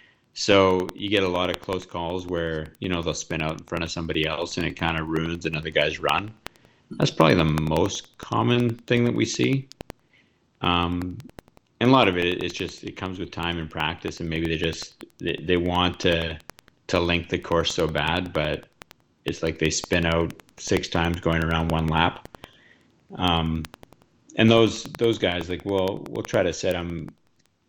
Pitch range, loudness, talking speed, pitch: 80-95 Hz, -24 LUFS, 190 wpm, 85 Hz